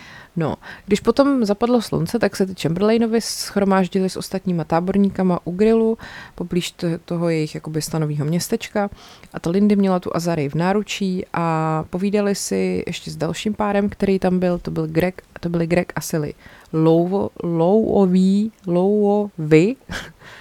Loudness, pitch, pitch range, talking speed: -20 LUFS, 185 Hz, 165-205 Hz, 145 wpm